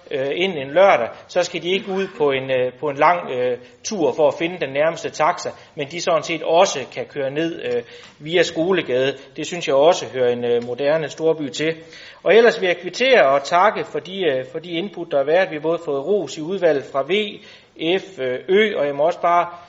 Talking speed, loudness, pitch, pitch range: 225 wpm, -19 LUFS, 160 Hz, 140-180 Hz